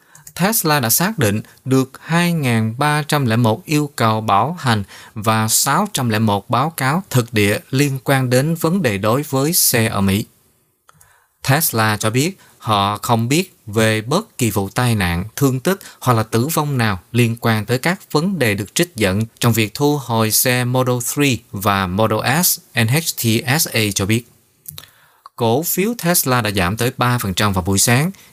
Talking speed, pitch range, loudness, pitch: 165 wpm, 110-150 Hz, -17 LUFS, 120 Hz